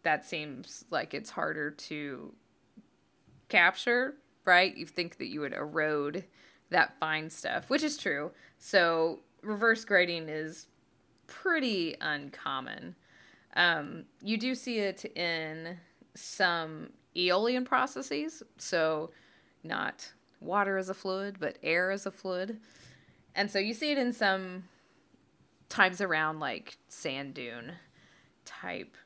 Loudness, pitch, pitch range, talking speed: -31 LUFS, 180 Hz, 155-215 Hz, 120 wpm